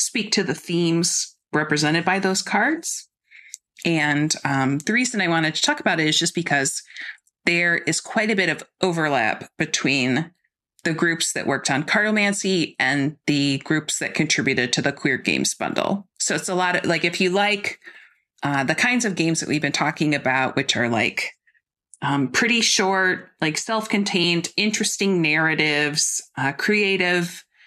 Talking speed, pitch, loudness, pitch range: 165 wpm, 170 Hz, -21 LUFS, 150-200 Hz